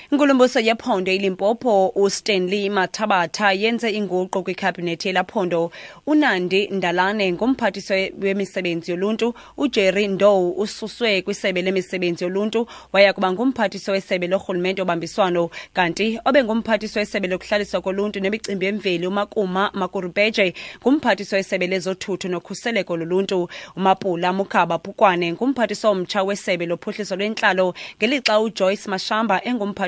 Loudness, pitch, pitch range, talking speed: -20 LUFS, 195 Hz, 185-210 Hz, 105 wpm